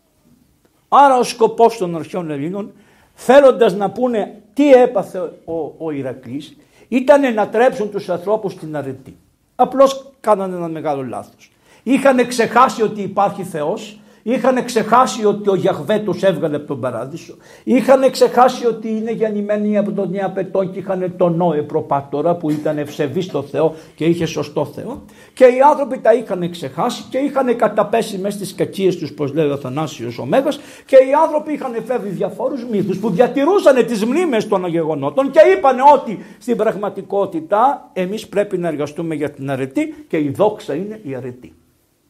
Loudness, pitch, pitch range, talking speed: -16 LUFS, 205 Hz, 170-245 Hz, 155 wpm